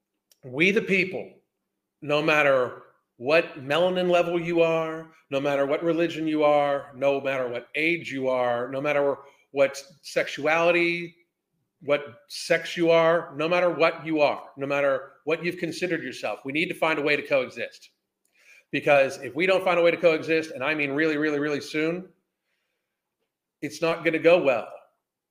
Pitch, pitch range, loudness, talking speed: 160 Hz, 140-170 Hz, -24 LUFS, 170 wpm